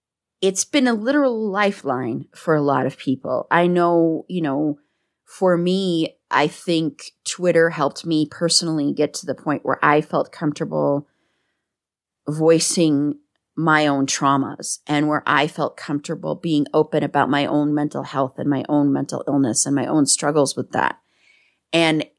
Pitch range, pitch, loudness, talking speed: 145-170 Hz, 150 Hz, -20 LUFS, 155 wpm